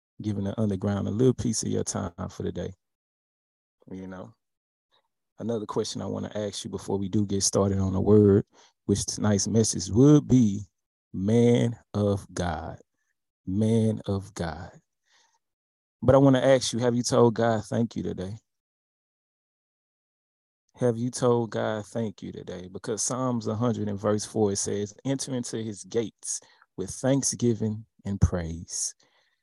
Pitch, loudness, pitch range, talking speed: 110 Hz, -26 LUFS, 100-120 Hz, 150 wpm